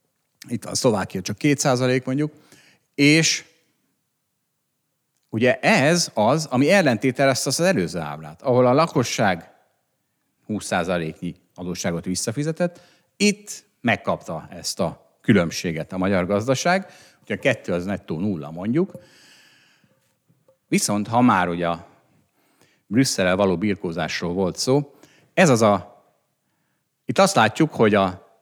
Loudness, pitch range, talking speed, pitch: -21 LUFS, 95-150 Hz, 110 wpm, 125 Hz